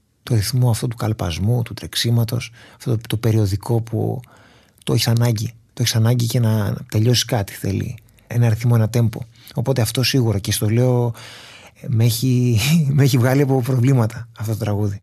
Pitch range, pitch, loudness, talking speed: 110-125 Hz, 120 Hz, -19 LUFS, 180 wpm